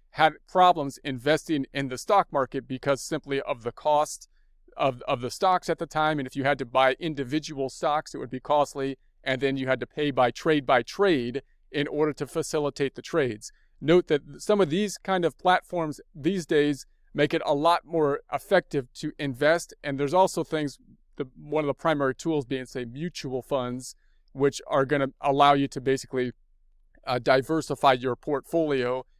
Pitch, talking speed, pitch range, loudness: 145 Hz, 185 wpm, 135-160 Hz, -26 LUFS